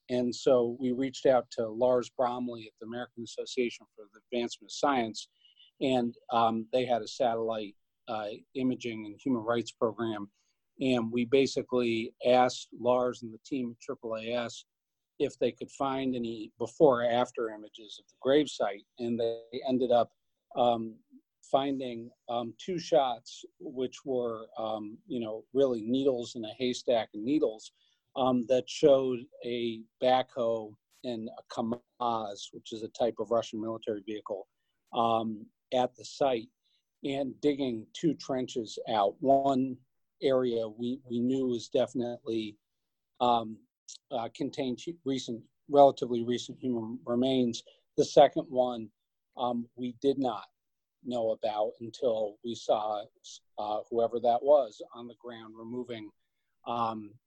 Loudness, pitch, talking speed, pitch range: -31 LUFS, 120 Hz, 140 wpm, 115-130 Hz